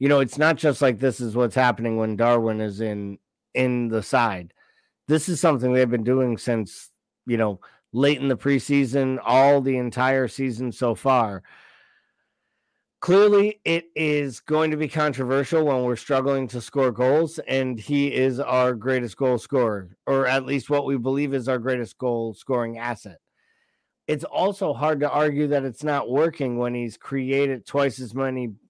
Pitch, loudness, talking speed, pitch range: 130 Hz, -23 LUFS, 175 wpm, 120-140 Hz